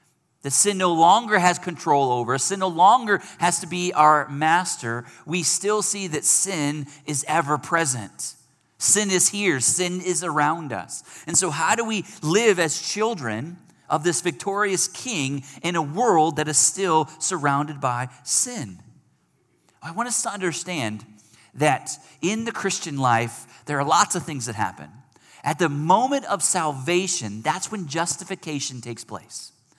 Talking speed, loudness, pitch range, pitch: 160 wpm, -22 LUFS, 140-185 Hz, 165 Hz